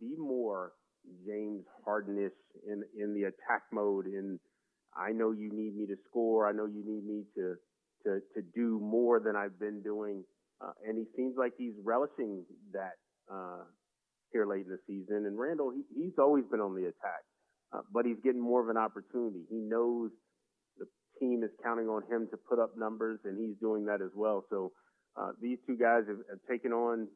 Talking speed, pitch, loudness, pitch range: 195 wpm, 110 Hz, -35 LUFS, 105-115 Hz